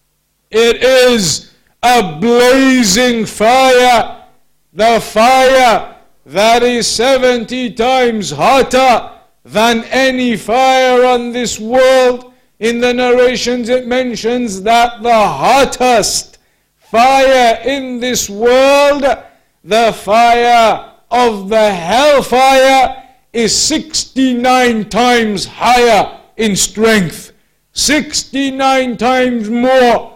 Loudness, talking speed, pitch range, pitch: -10 LUFS, 90 wpm, 225-255 Hz, 245 Hz